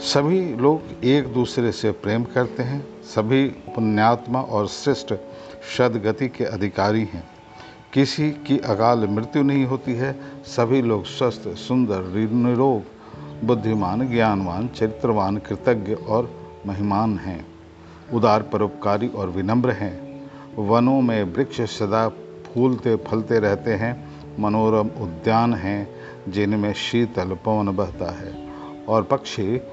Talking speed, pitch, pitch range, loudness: 115 wpm, 110 Hz, 100-125 Hz, -22 LUFS